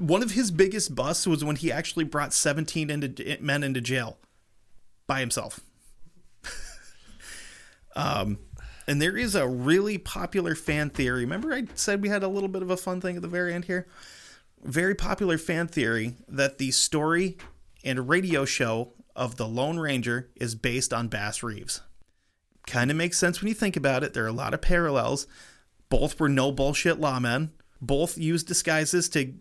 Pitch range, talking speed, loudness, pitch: 130-175 Hz, 175 wpm, -27 LUFS, 155 Hz